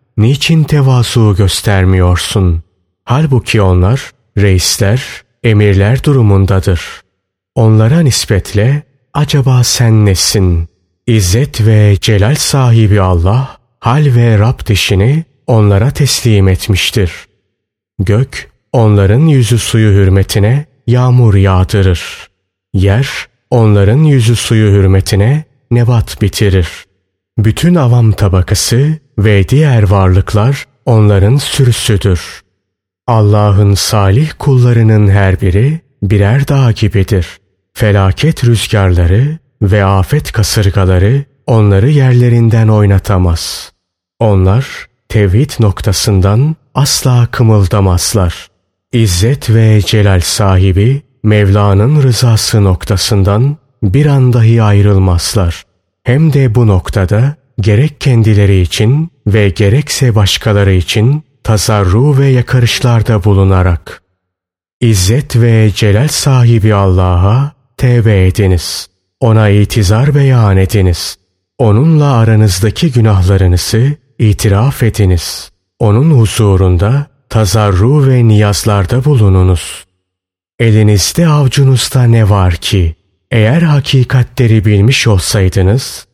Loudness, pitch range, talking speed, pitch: -9 LUFS, 95-125 Hz, 85 wpm, 110 Hz